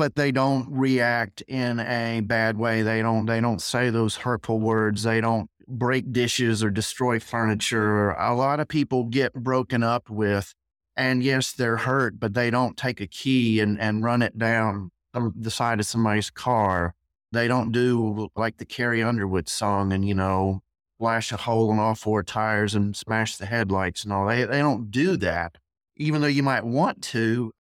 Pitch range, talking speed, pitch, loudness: 105-125 Hz, 185 wpm, 115 Hz, -24 LUFS